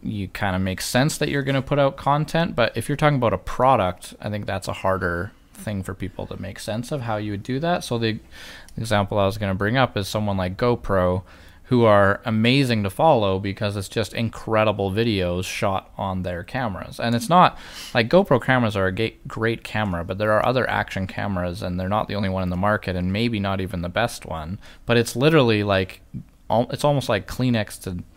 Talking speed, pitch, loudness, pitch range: 220 wpm, 105 Hz, -22 LUFS, 95-120 Hz